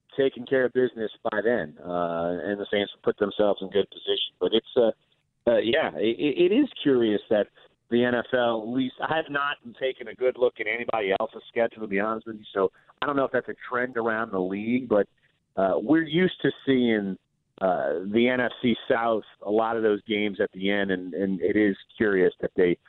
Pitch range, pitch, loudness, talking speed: 100-130 Hz, 115 Hz, -26 LUFS, 215 wpm